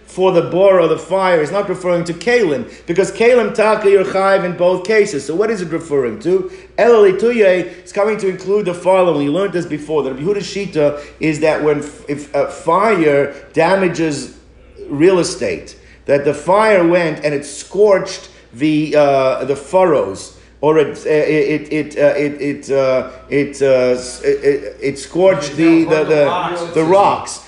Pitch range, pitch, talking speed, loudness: 150-200 Hz, 175 Hz, 145 wpm, -15 LUFS